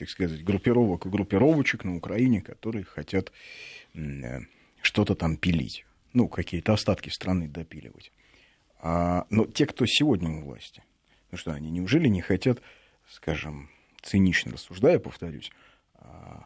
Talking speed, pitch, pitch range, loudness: 125 wpm, 95 Hz, 80-110 Hz, -26 LUFS